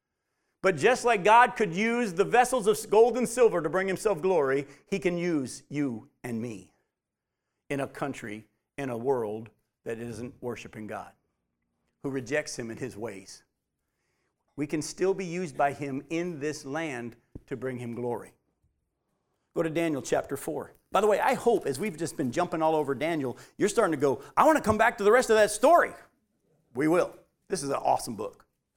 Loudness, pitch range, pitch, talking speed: -27 LUFS, 120-205 Hz, 150 Hz, 190 wpm